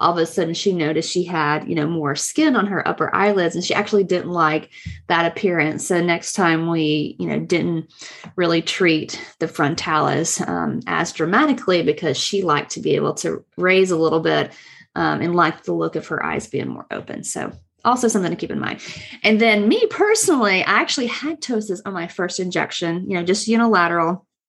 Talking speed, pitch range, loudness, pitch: 200 wpm, 165-205 Hz, -19 LUFS, 175 Hz